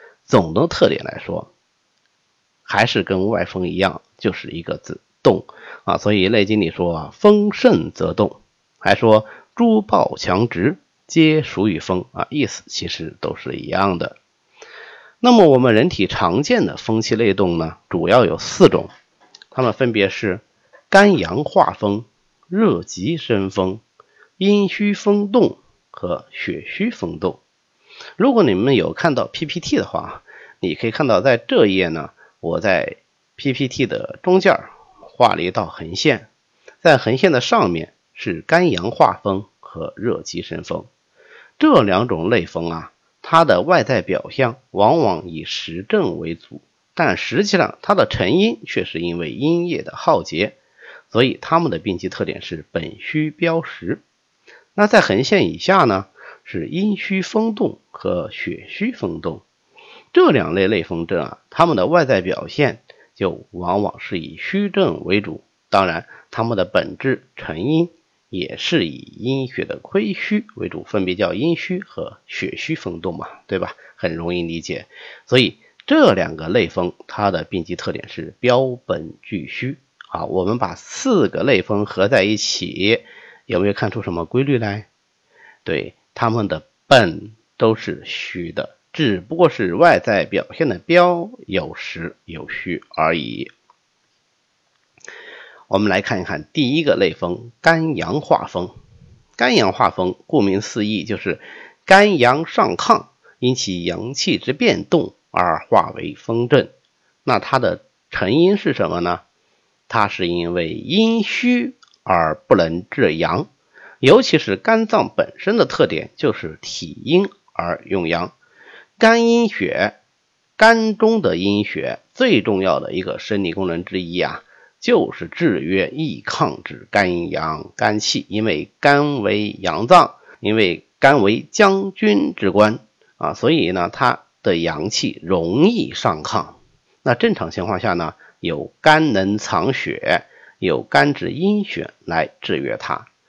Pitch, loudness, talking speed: 135 Hz, -18 LUFS, 205 characters per minute